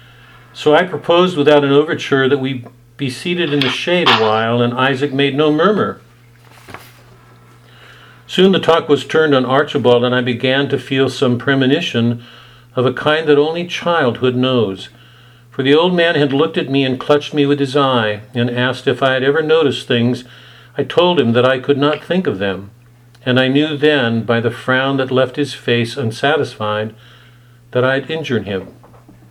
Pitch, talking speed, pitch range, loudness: 130 Hz, 185 wpm, 120-145 Hz, -15 LUFS